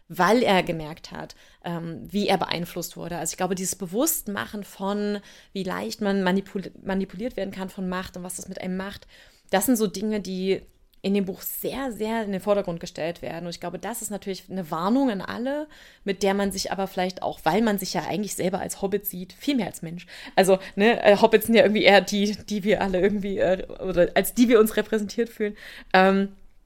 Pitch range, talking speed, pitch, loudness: 185-210 Hz, 205 wpm, 195 Hz, -24 LUFS